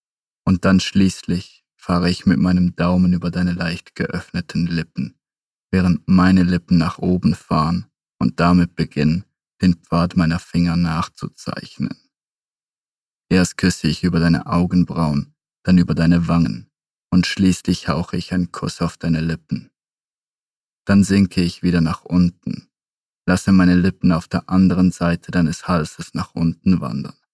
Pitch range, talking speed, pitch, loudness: 85-90 Hz, 140 wpm, 90 Hz, -18 LUFS